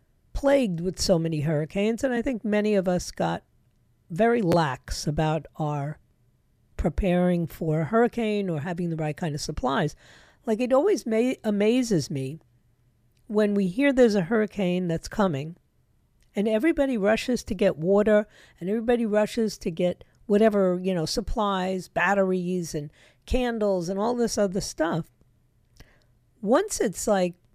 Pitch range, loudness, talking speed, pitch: 155-220 Hz, -25 LUFS, 145 wpm, 190 Hz